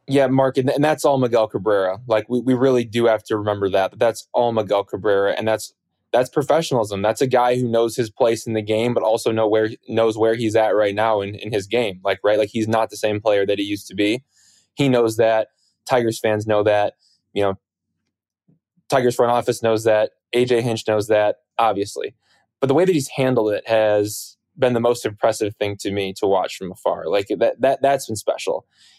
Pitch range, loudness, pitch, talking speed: 105-125 Hz, -20 LUFS, 110 Hz, 220 wpm